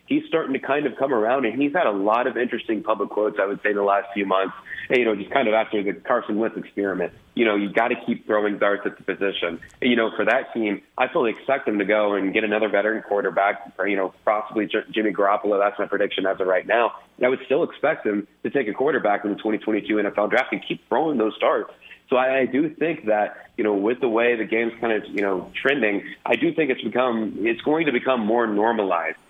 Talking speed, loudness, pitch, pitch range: 255 wpm, -22 LUFS, 110 Hz, 100-125 Hz